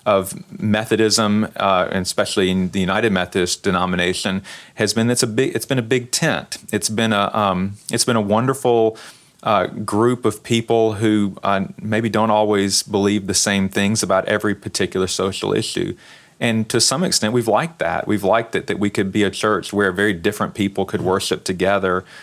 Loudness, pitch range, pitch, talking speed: -19 LUFS, 100-110 Hz, 105 Hz, 185 wpm